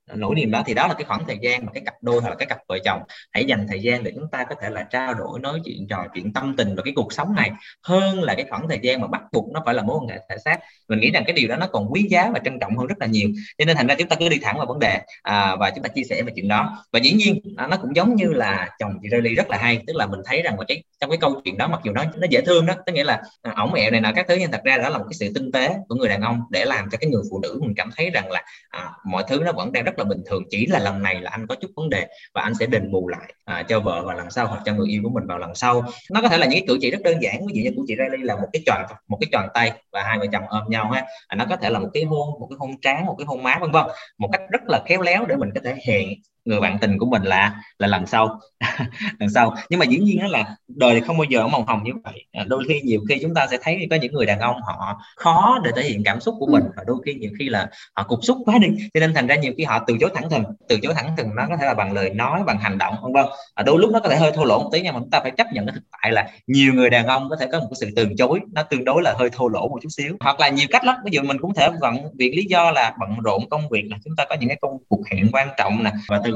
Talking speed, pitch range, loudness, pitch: 335 wpm, 115-175 Hz, -20 LUFS, 135 Hz